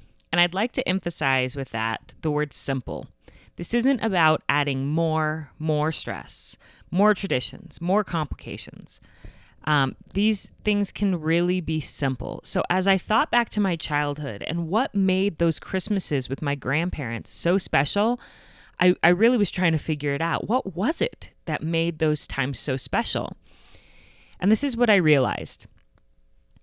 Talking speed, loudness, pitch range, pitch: 160 wpm, -24 LUFS, 140-195 Hz, 165 Hz